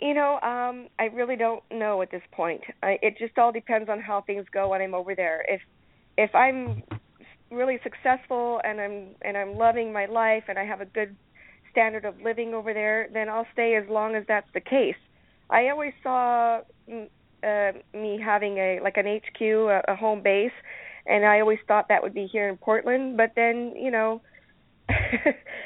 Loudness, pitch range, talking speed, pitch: -25 LUFS, 200-235 Hz, 190 wpm, 220 Hz